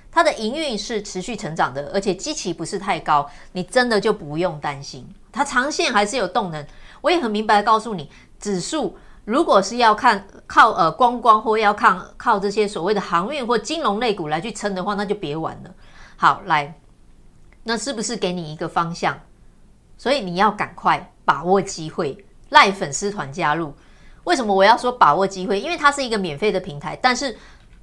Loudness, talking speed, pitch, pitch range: -20 LUFS, 285 characters per minute, 205 Hz, 185-230 Hz